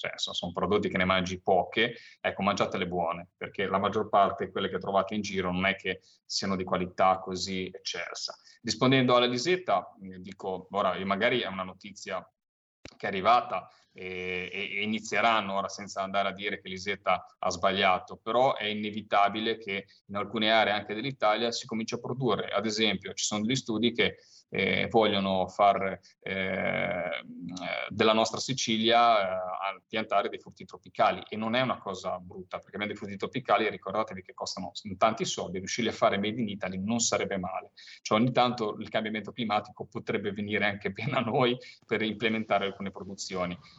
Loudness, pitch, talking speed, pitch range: -29 LUFS, 100 Hz, 170 wpm, 95-110 Hz